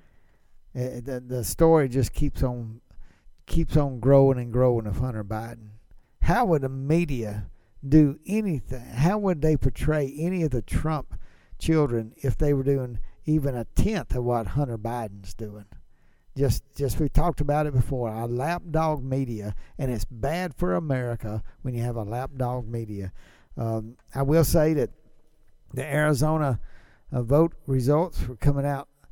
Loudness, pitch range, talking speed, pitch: -26 LUFS, 115-150 Hz, 155 wpm, 130 Hz